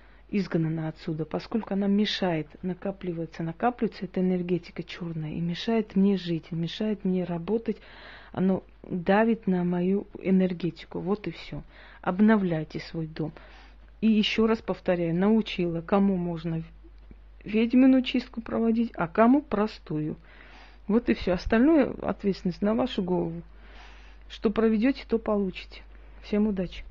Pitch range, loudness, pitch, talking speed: 170-215 Hz, -27 LUFS, 185 Hz, 125 wpm